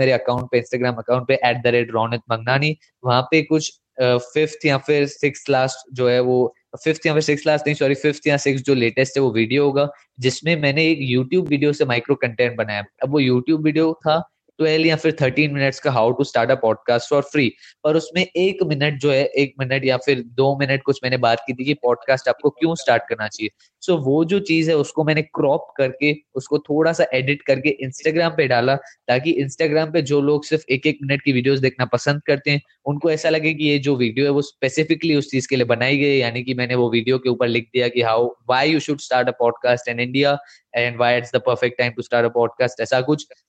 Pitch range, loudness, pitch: 125-150 Hz, -19 LUFS, 135 Hz